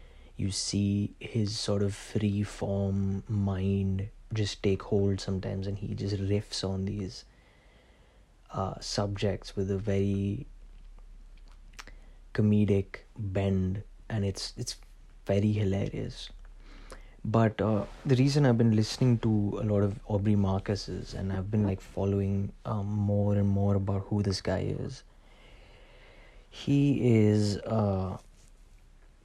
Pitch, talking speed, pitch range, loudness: 100 Hz, 125 wpm, 95-105 Hz, -30 LUFS